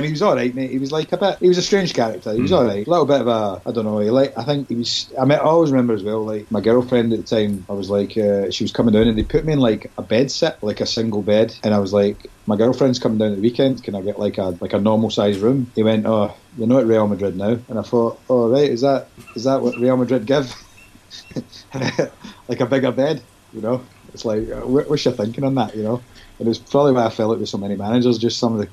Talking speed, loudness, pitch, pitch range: 295 wpm, -19 LUFS, 115 Hz, 105-130 Hz